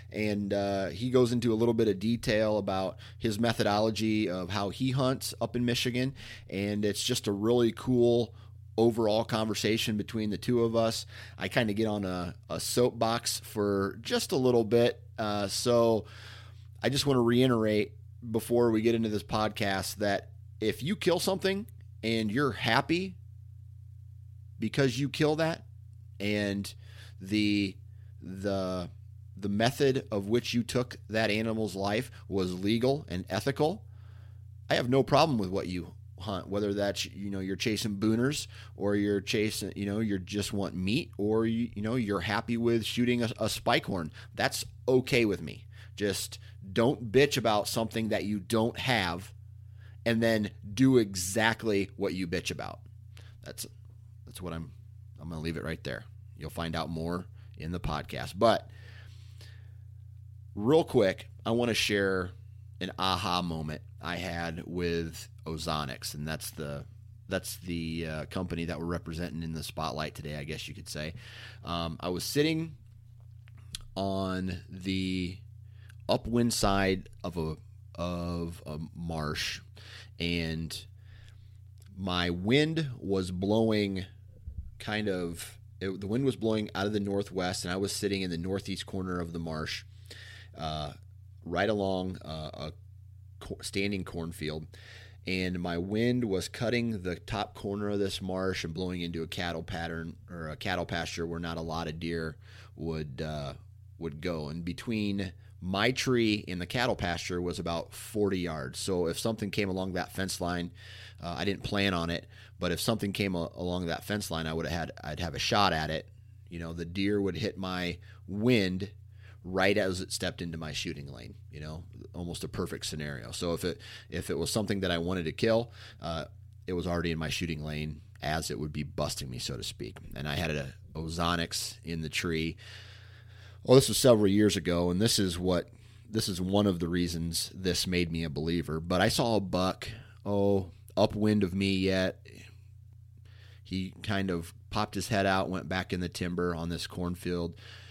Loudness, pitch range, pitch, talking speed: -31 LUFS, 90-110 Hz, 100 Hz, 170 wpm